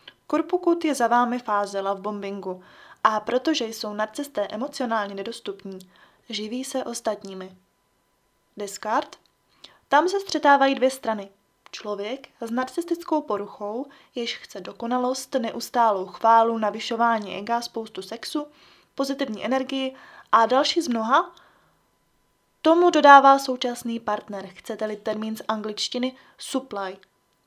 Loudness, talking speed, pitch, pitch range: -23 LUFS, 110 wpm, 230 Hz, 210-270 Hz